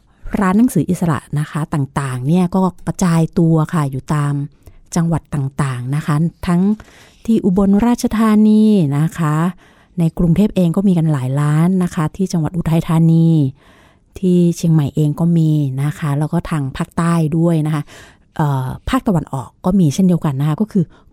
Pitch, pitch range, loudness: 165 Hz, 150-180 Hz, -16 LUFS